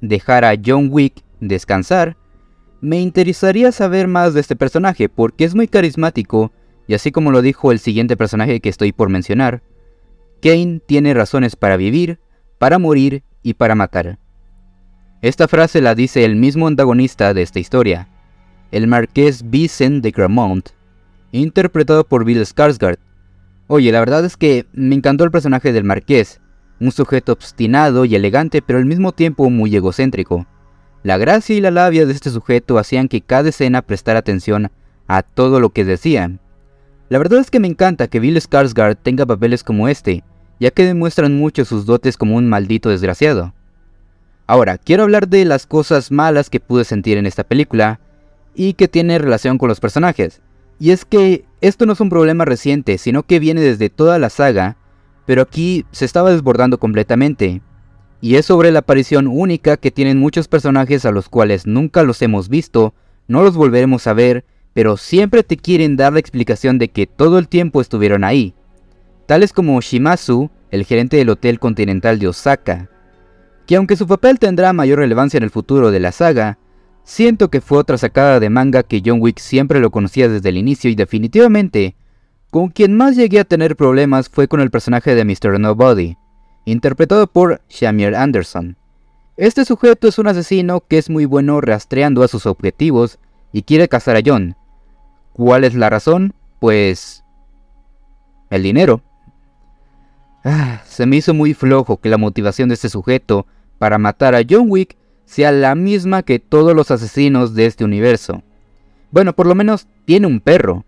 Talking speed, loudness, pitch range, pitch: 170 wpm, -13 LUFS, 105-150 Hz, 125 Hz